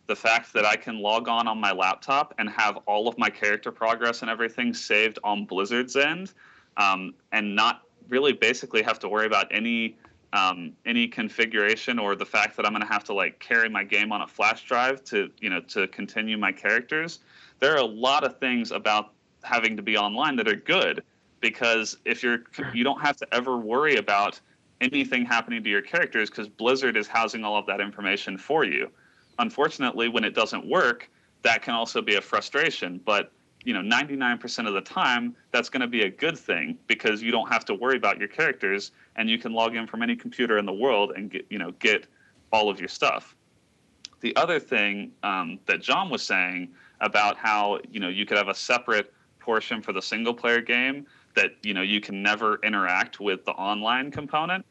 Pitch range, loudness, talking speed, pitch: 105-125 Hz, -25 LUFS, 205 wpm, 115 Hz